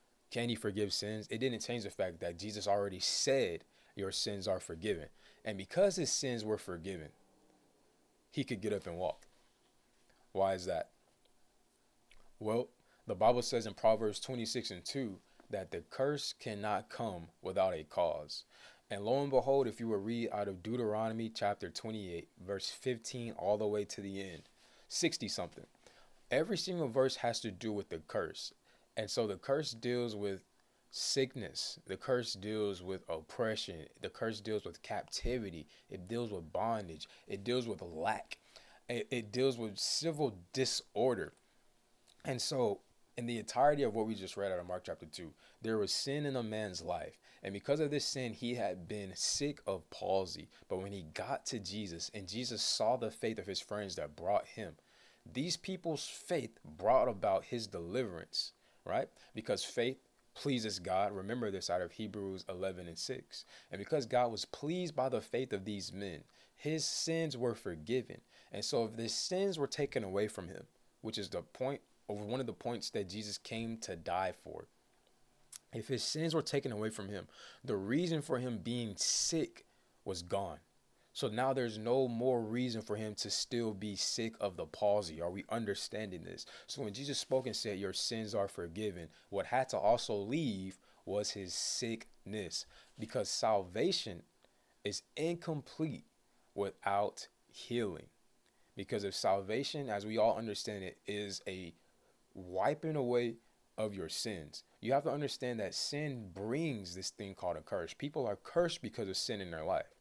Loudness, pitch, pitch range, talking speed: -38 LUFS, 110 Hz, 100-130 Hz, 175 wpm